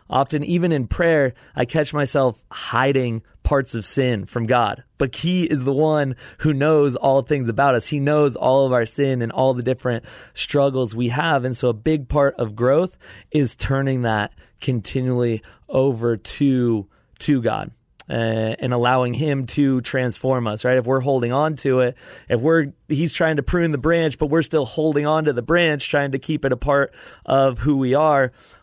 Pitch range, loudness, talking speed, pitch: 125-150 Hz, -20 LUFS, 195 wpm, 135 Hz